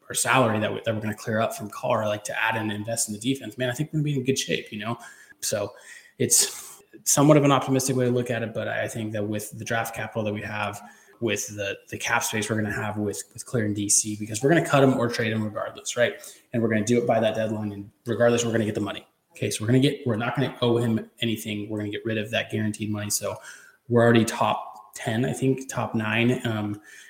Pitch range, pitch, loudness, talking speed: 105-125 Hz, 115 Hz, -25 LUFS, 285 wpm